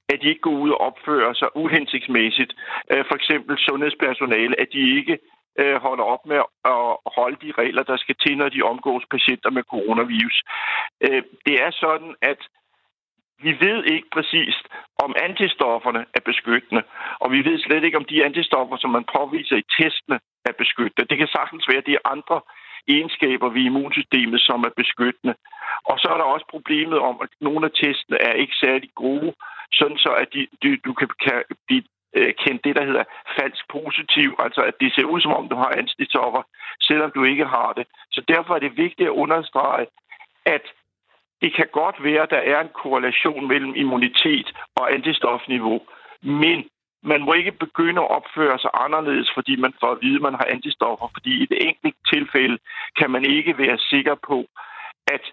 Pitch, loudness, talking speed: 165 Hz, -20 LUFS, 175 wpm